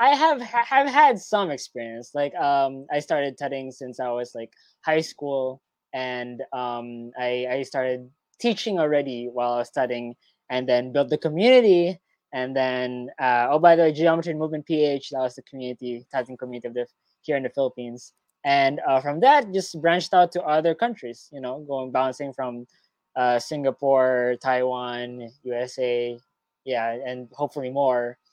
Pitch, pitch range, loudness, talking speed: 130 Hz, 125-150 Hz, -23 LUFS, 165 wpm